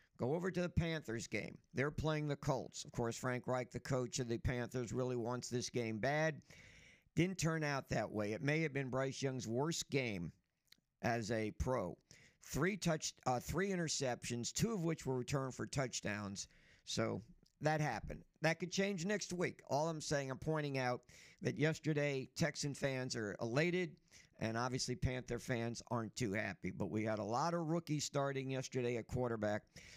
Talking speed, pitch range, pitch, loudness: 180 wpm, 120-155 Hz, 130 Hz, -40 LUFS